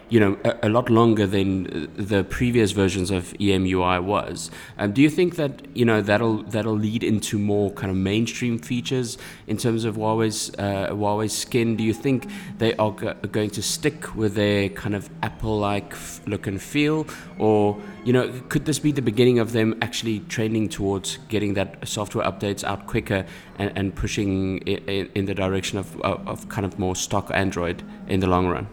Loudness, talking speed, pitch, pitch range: -23 LUFS, 195 wpm, 105 Hz, 100-115 Hz